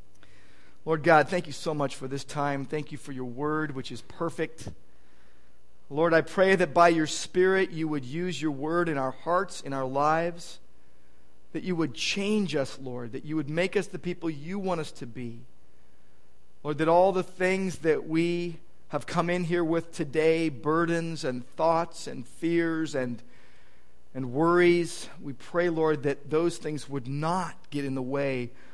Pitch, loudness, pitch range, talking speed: 155 Hz, -28 LUFS, 130-170 Hz, 180 wpm